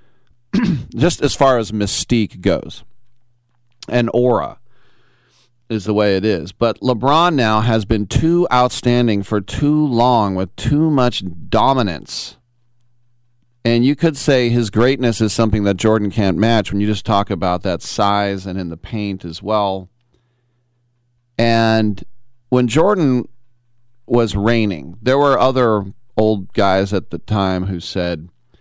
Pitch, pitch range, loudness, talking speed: 115 Hz, 100-120 Hz, -16 LUFS, 140 wpm